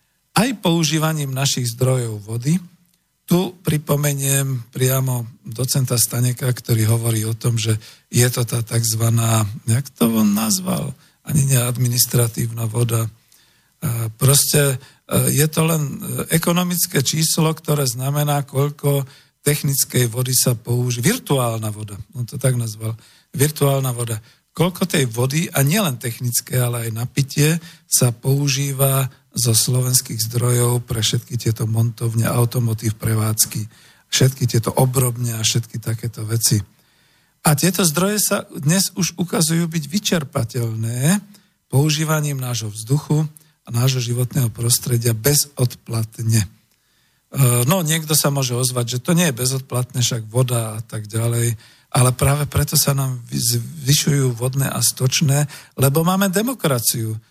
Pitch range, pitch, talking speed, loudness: 120-155 Hz, 130 Hz, 125 wpm, -19 LUFS